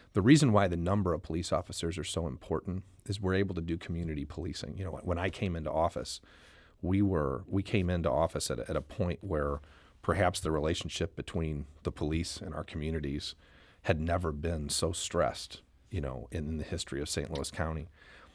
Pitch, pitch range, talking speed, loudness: 85 Hz, 75-95 Hz, 195 wpm, -33 LUFS